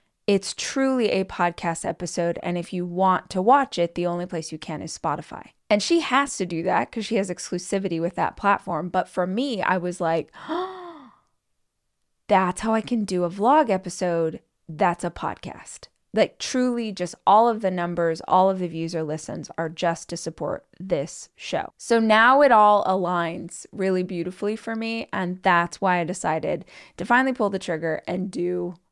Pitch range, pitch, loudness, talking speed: 170-215 Hz, 185 Hz, -23 LUFS, 185 wpm